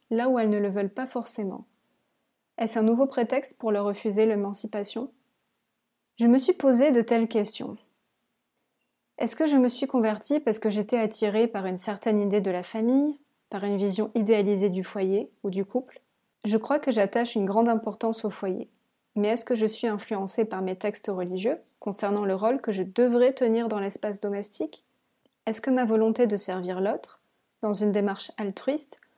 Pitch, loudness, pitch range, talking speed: 220 Hz, -26 LUFS, 205-240 Hz, 185 wpm